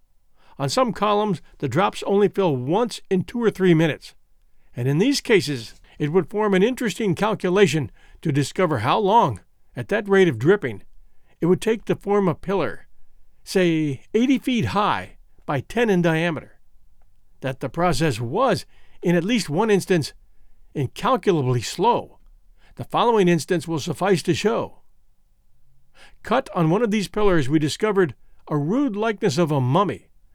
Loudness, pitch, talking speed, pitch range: -21 LUFS, 175 Hz, 155 wpm, 135-205 Hz